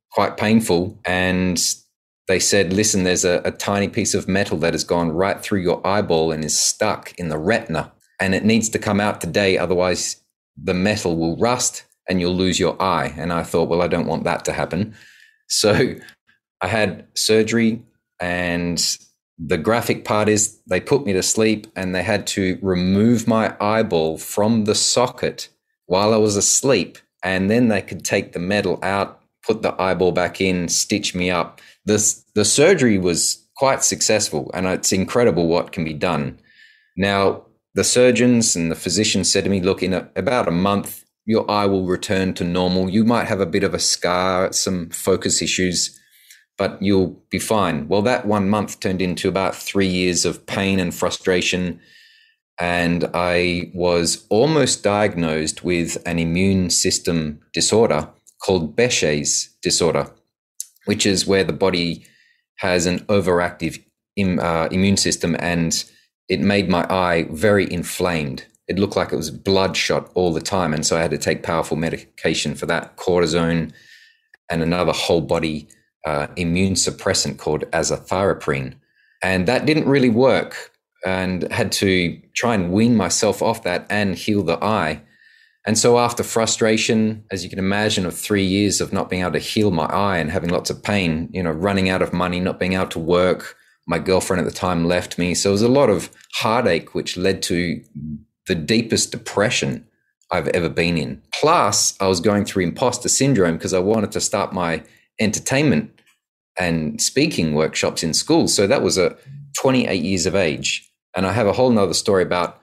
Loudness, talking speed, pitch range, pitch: -19 LUFS, 175 wpm, 85-105 Hz, 95 Hz